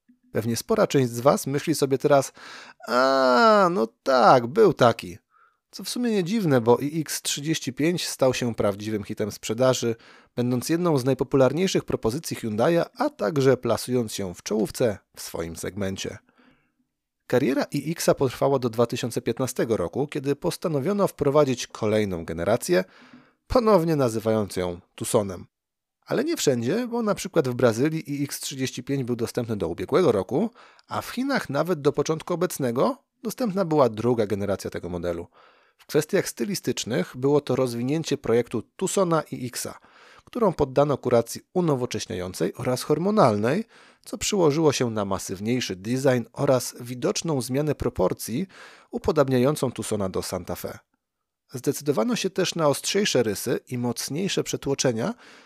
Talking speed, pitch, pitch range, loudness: 135 wpm, 135 Hz, 120-165 Hz, -24 LUFS